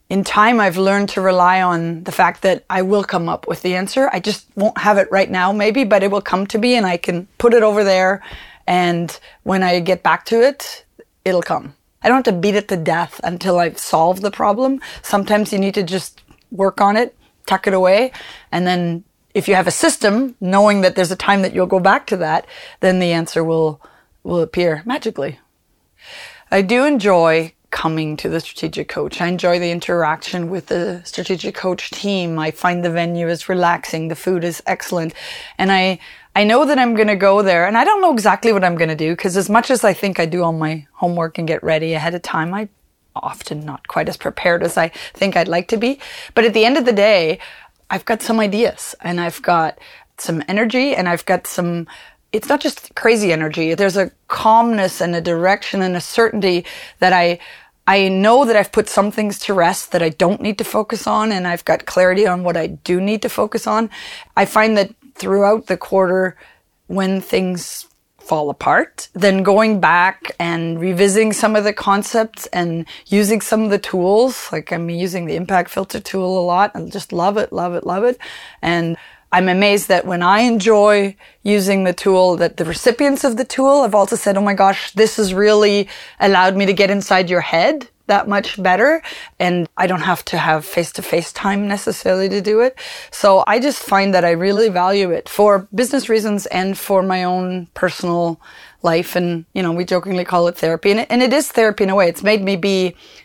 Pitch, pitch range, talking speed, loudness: 195 Hz, 175-215 Hz, 210 wpm, -16 LUFS